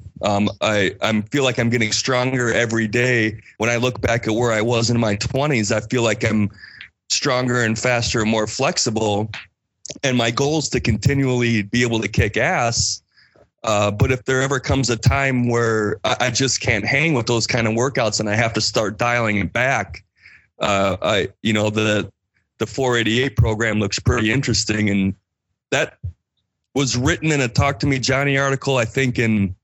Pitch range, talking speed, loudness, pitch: 110-130 Hz, 190 wpm, -19 LUFS, 115 Hz